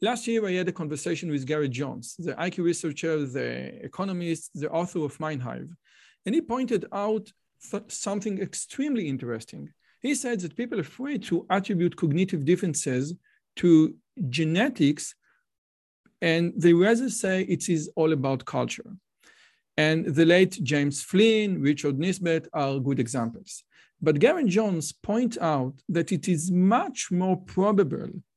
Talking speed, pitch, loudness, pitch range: 145 wpm, 175 Hz, -26 LUFS, 155-200 Hz